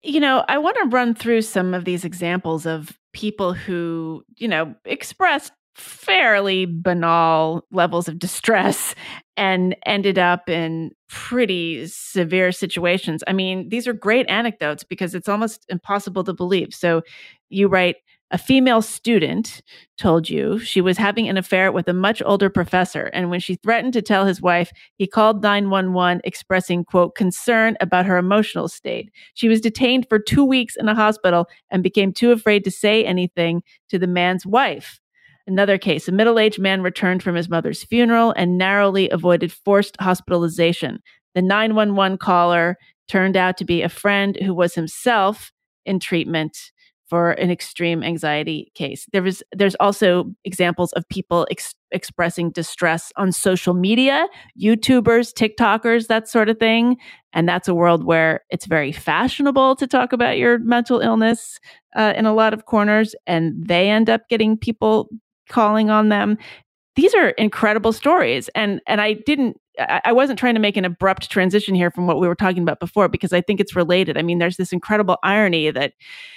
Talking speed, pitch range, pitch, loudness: 170 wpm, 175-220 Hz, 190 Hz, -18 LUFS